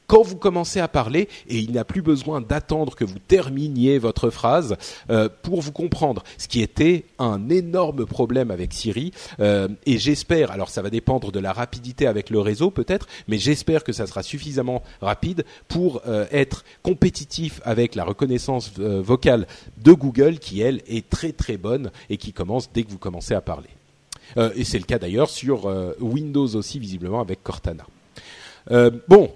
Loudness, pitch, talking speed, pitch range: -22 LUFS, 125 Hz, 185 wpm, 110-150 Hz